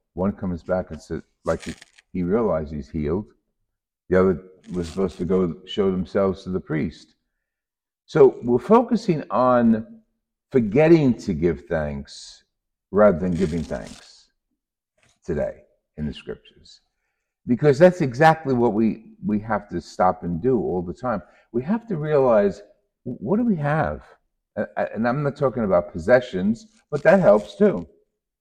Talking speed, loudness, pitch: 150 wpm, -21 LUFS, 120 Hz